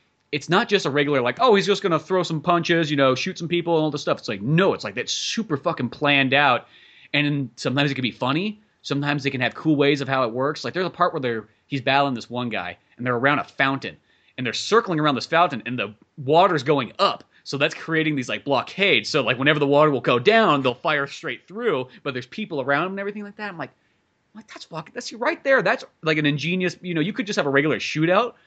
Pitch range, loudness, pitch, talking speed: 135-175 Hz, -22 LUFS, 150 Hz, 260 wpm